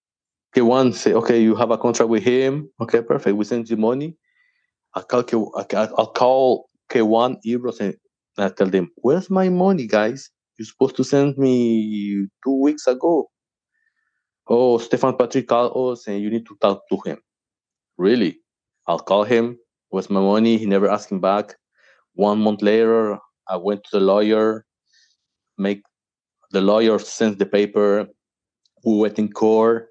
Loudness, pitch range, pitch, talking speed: -19 LUFS, 105-130 Hz, 115 Hz, 150 wpm